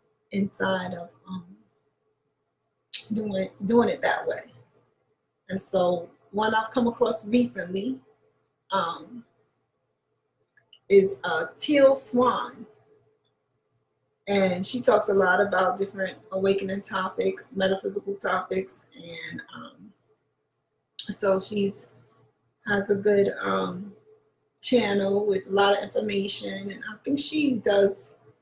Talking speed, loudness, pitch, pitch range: 105 wpm, -25 LUFS, 200 Hz, 190-235 Hz